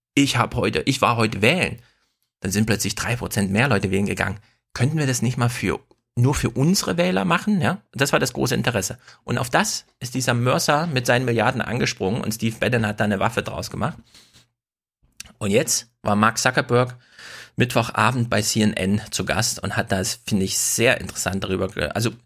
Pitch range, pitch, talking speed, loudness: 100-125 Hz, 115 Hz, 190 wpm, -21 LUFS